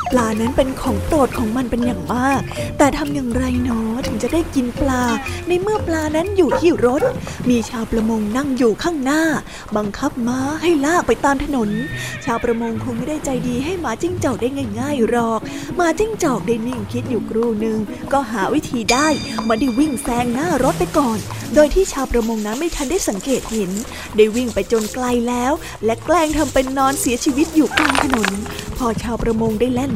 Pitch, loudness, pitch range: 250 Hz, -19 LUFS, 230-295 Hz